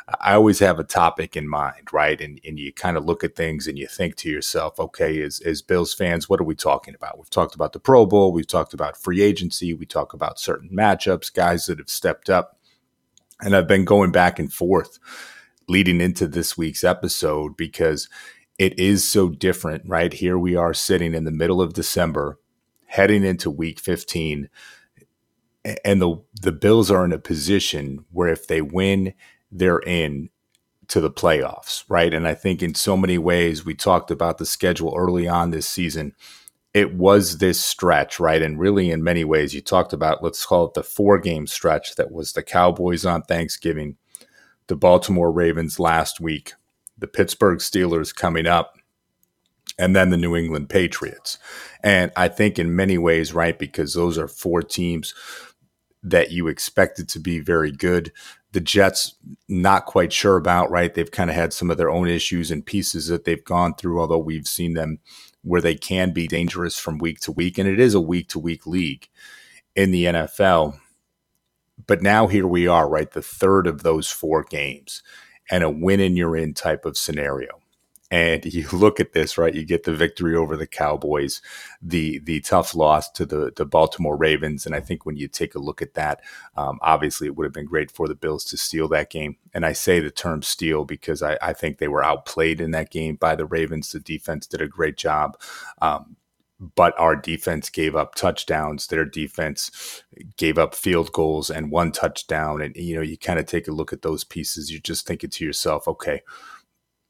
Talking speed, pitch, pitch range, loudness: 195 wpm, 85 Hz, 80-90 Hz, -21 LUFS